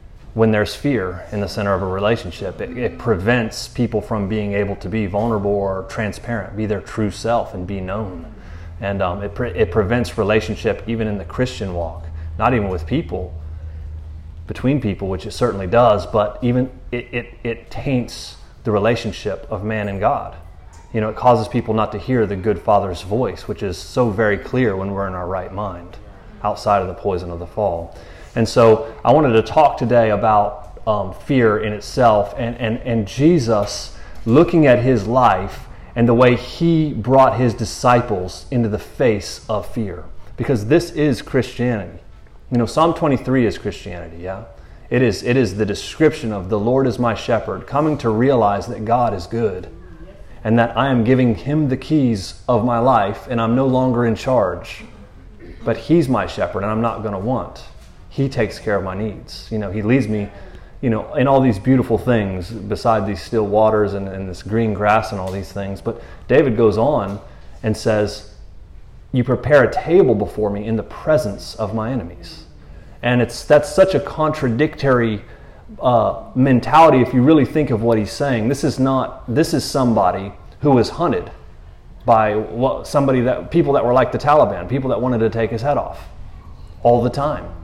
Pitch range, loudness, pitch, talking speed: 100-125 Hz, -18 LUFS, 110 Hz, 190 wpm